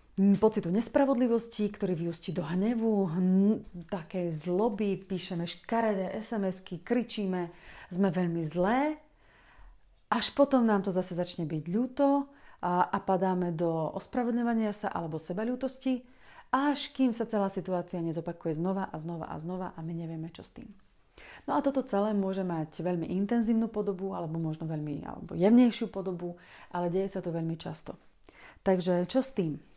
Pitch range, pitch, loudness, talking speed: 175-225 Hz, 190 Hz, -31 LUFS, 150 wpm